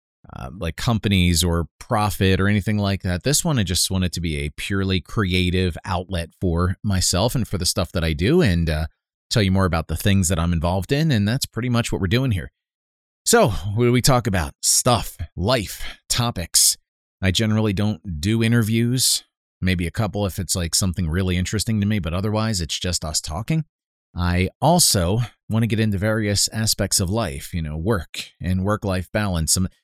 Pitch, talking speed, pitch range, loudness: 95 Hz, 195 wpm, 85-110 Hz, -21 LUFS